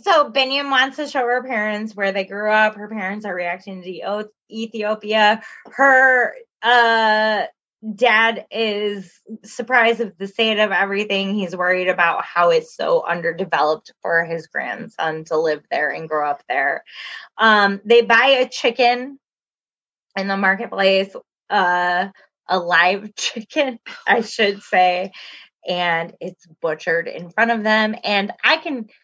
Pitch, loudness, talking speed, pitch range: 210 Hz, -18 LUFS, 145 wpm, 185-235 Hz